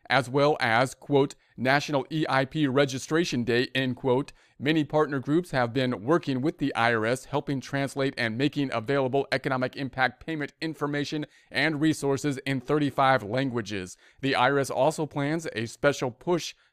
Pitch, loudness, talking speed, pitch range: 140 Hz, -27 LUFS, 145 wpm, 130-145 Hz